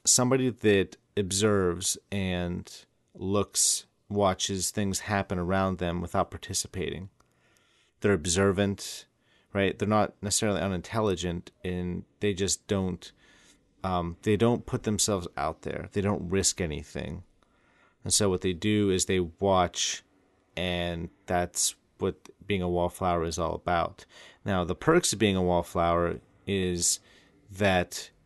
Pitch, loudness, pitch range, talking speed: 95 Hz, -28 LUFS, 90-100 Hz, 125 wpm